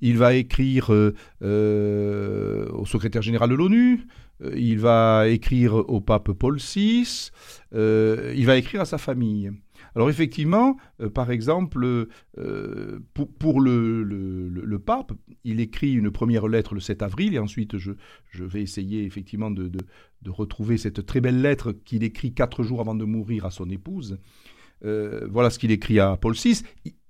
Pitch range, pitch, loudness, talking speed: 105-125 Hz, 115 Hz, -23 LUFS, 175 wpm